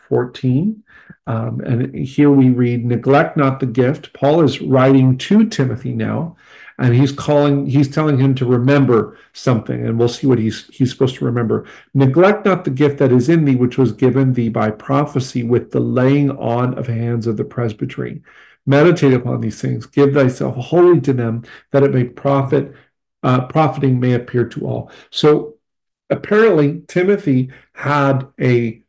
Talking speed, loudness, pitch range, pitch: 170 wpm, -16 LUFS, 120-145 Hz, 135 Hz